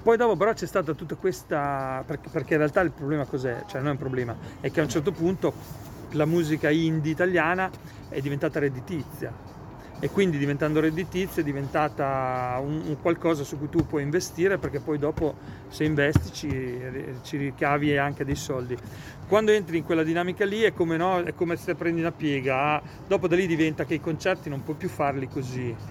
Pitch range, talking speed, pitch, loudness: 140-170 Hz, 195 wpm, 155 Hz, -26 LUFS